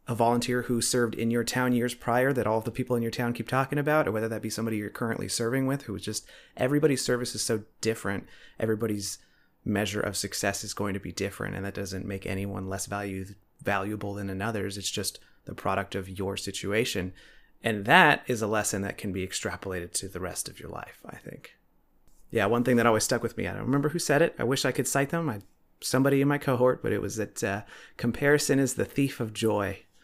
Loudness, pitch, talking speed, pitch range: -28 LUFS, 110 Hz, 230 wpm, 100-125 Hz